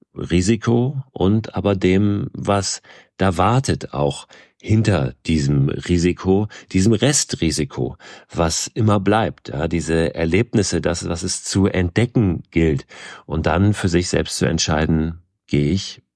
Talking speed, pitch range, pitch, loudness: 125 wpm, 80-105 Hz, 95 Hz, -19 LUFS